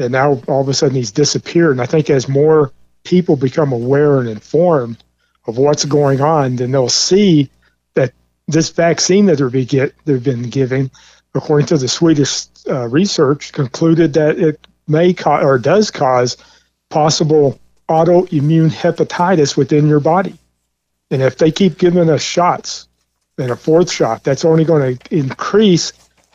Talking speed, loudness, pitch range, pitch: 155 wpm, -14 LUFS, 130-165 Hz, 145 Hz